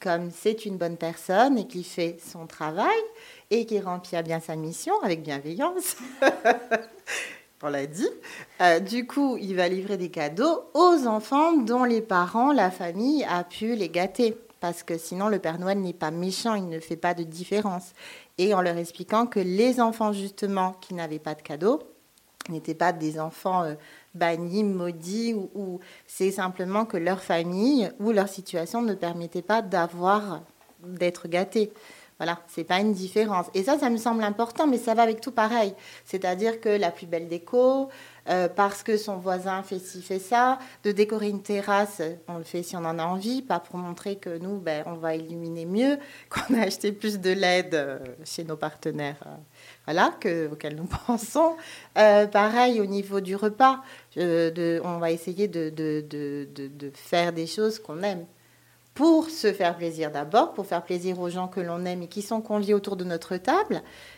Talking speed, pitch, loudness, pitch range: 190 wpm, 185 Hz, -26 LUFS, 170-220 Hz